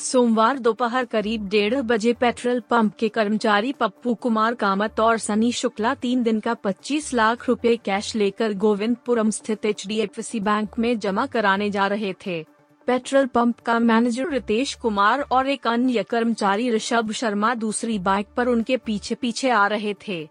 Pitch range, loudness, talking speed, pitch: 210-240 Hz, -22 LUFS, 160 wpm, 230 Hz